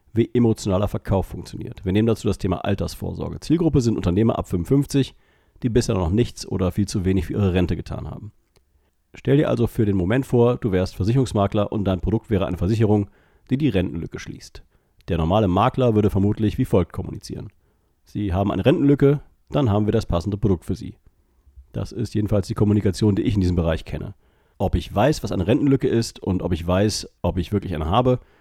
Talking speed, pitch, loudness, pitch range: 200 wpm, 105 Hz, -21 LUFS, 90-115 Hz